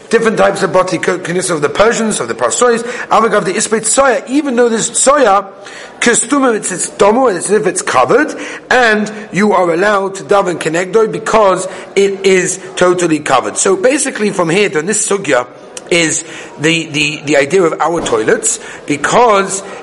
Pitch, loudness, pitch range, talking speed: 195 Hz, -12 LUFS, 180-225 Hz, 160 wpm